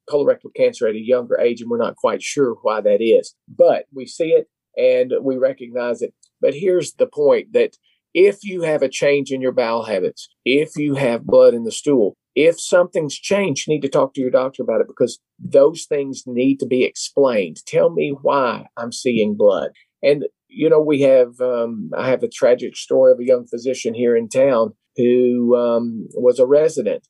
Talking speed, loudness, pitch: 200 wpm, -18 LUFS, 205 Hz